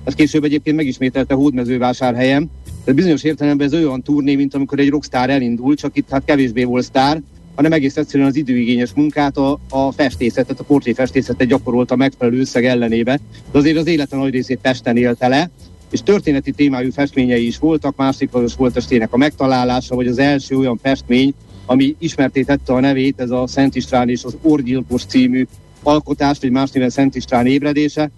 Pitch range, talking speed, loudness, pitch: 125-145 Hz, 180 wpm, -16 LUFS, 135 Hz